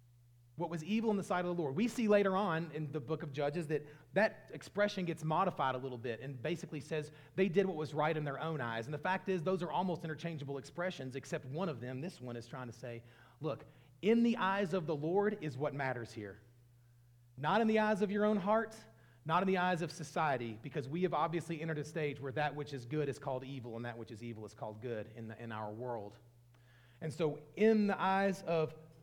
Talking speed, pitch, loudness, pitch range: 240 wpm, 155 Hz, -37 LUFS, 125-180 Hz